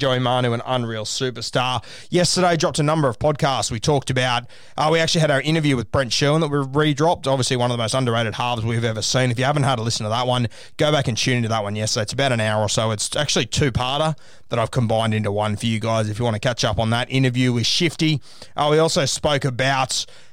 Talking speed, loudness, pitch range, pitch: 255 wpm, -20 LUFS, 115-150 Hz, 130 Hz